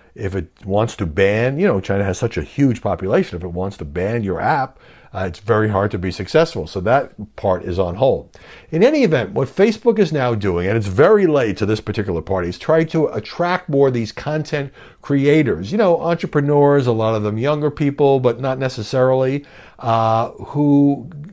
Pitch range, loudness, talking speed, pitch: 95-145 Hz, -18 LUFS, 205 wpm, 115 Hz